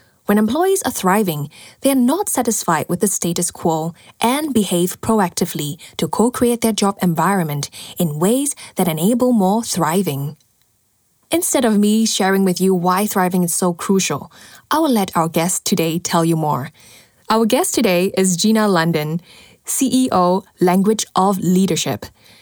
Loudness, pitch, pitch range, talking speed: -17 LUFS, 185 Hz, 165-220 Hz, 155 wpm